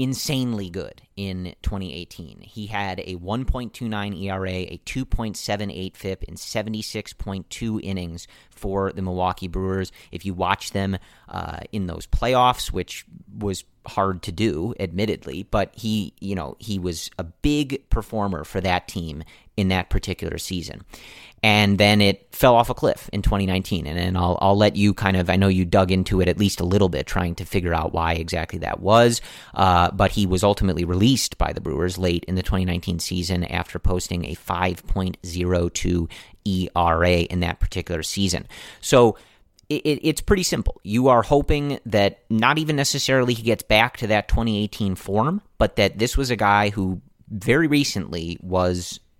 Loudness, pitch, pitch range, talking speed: -22 LUFS, 95 Hz, 90-110 Hz, 170 wpm